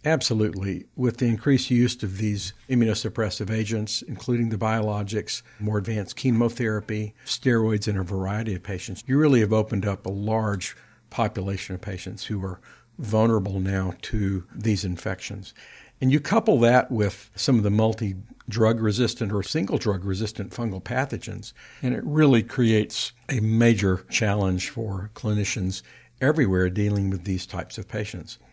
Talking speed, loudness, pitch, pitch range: 150 wpm, -25 LUFS, 110 Hz, 100-115 Hz